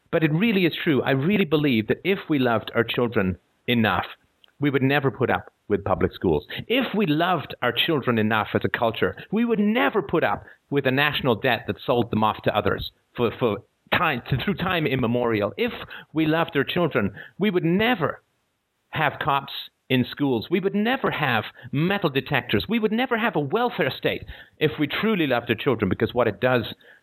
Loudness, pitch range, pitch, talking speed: -23 LUFS, 120-185 Hz, 145 Hz, 195 wpm